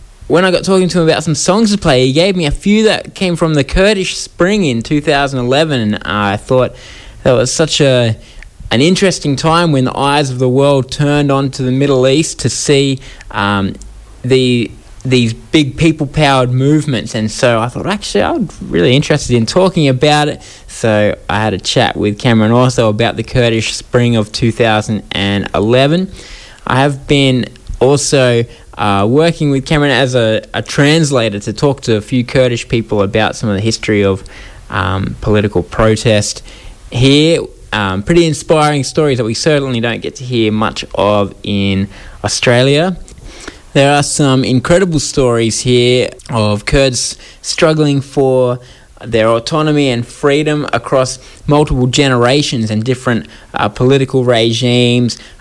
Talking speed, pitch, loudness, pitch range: 160 wpm, 125 Hz, -12 LUFS, 110-145 Hz